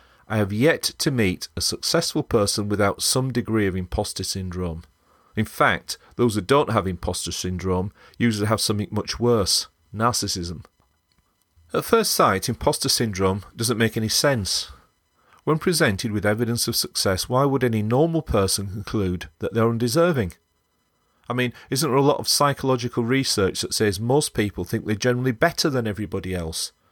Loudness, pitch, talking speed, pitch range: -22 LUFS, 110 Hz, 160 wpm, 95-125 Hz